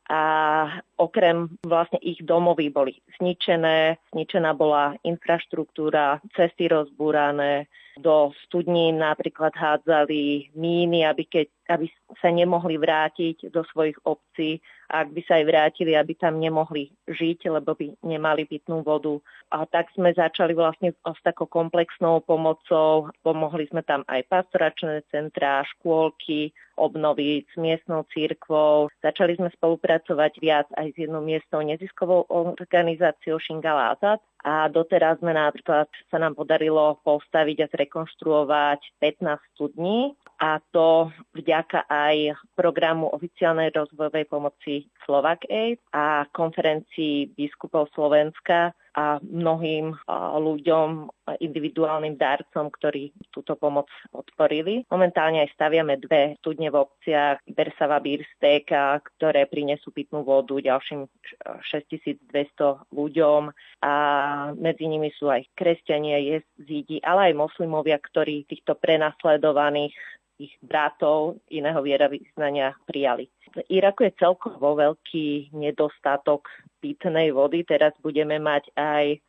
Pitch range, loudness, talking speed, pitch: 150-165 Hz, -23 LUFS, 115 wpm, 155 Hz